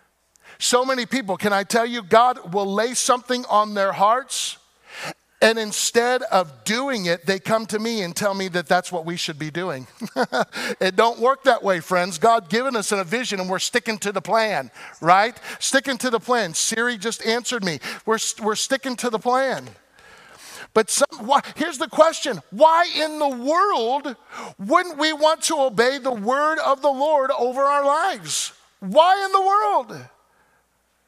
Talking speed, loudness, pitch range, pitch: 180 wpm, -20 LUFS, 205-270 Hz, 235 Hz